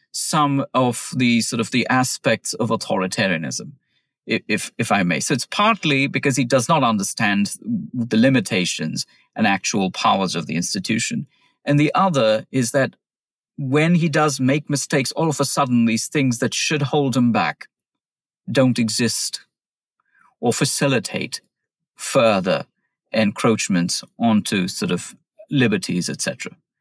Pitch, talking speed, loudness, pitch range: 140 Hz, 135 wpm, -20 LUFS, 125-155 Hz